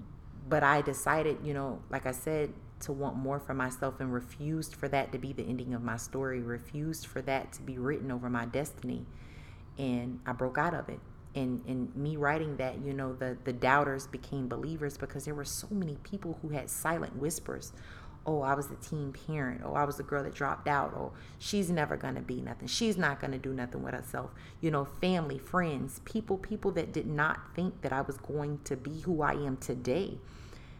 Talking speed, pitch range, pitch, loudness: 215 wpm, 130-150 Hz, 140 Hz, -34 LUFS